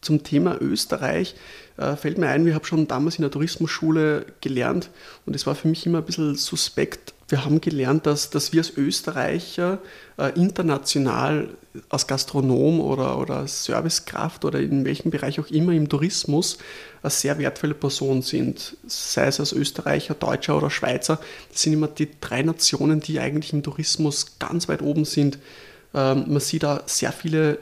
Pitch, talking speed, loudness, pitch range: 150 Hz, 165 wpm, -23 LUFS, 145-160 Hz